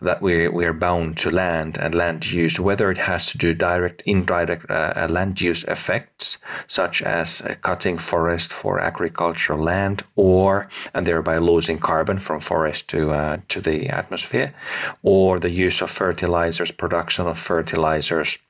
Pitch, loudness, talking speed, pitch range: 85 Hz, -21 LUFS, 160 wpm, 80-90 Hz